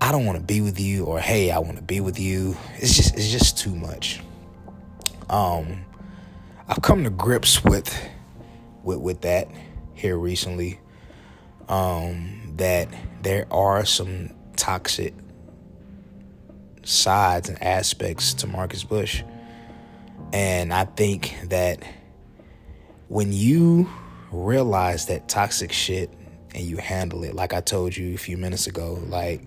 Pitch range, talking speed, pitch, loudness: 85-100 Hz, 135 wpm, 90 Hz, -23 LUFS